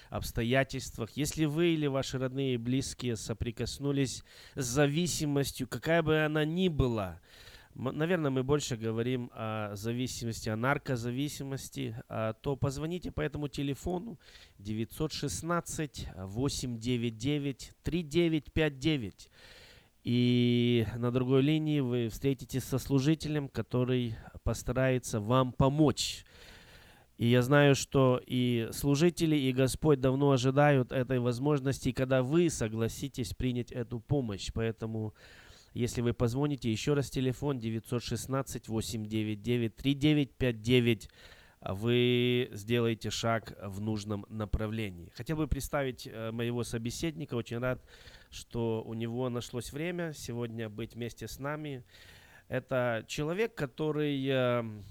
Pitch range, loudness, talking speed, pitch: 115-140 Hz, -32 LUFS, 105 wpm, 125 Hz